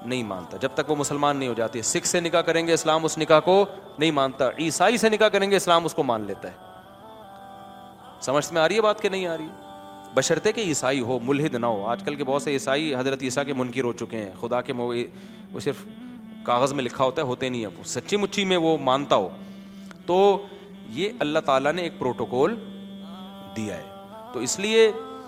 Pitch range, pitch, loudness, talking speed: 130-195 Hz, 160 Hz, -24 LUFS, 205 wpm